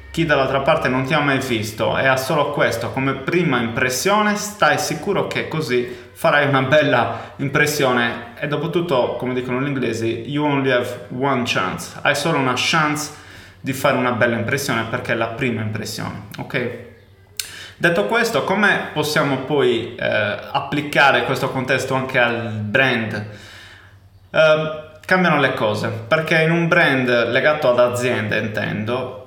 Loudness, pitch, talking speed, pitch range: -18 LUFS, 130 Hz, 150 wpm, 115-150 Hz